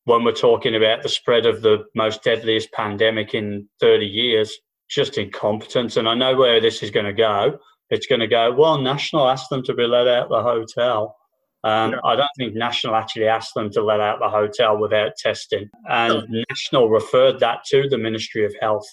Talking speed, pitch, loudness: 200 wpm, 120 Hz, -19 LUFS